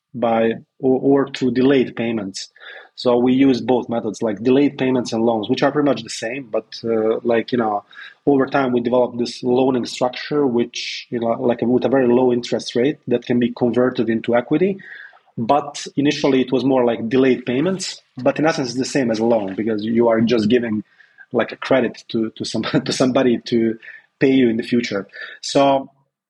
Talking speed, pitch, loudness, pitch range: 200 wpm, 125 Hz, -19 LUFS, 115-135 Hz